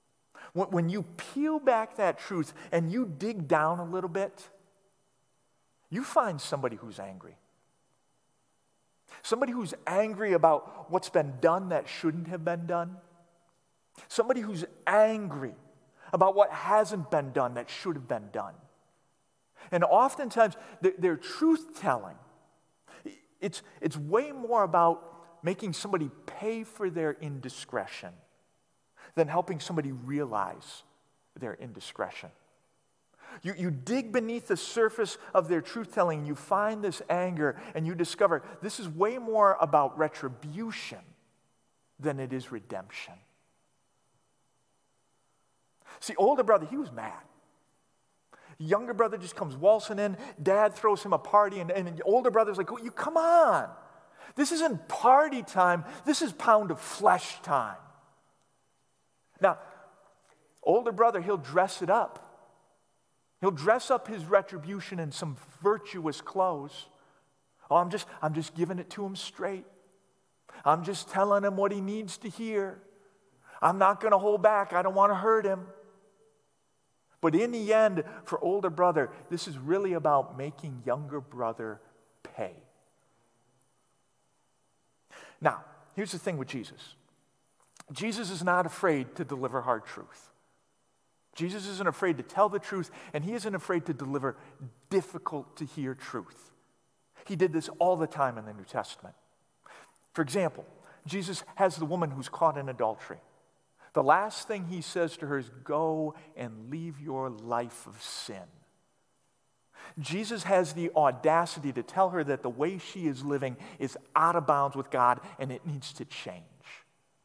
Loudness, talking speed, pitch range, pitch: -29 LUFS, 140 wpm, 150-205 Hz, 180 Hz